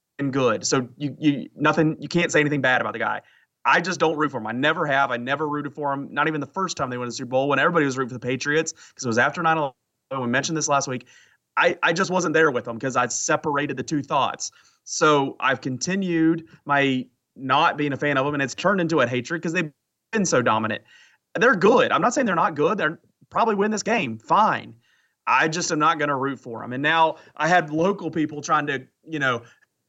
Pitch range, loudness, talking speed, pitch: 130-160 Hz, -22 LUFS, 245 wpm, 145 Hz